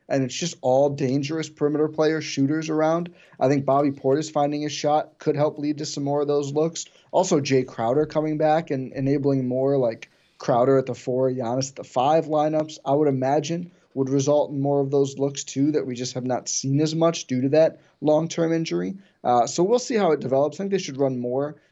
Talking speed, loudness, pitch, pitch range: 220 wpm, -23 LUFS, 145 Hz, 135-155 Hz